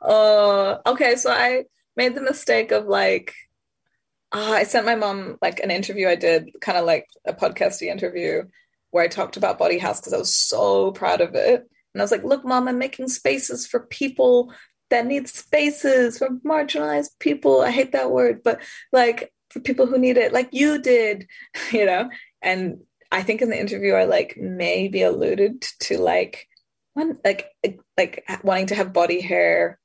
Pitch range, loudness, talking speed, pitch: 180-265 Hz, -21 LUFS, 185 wpm, 235 Hz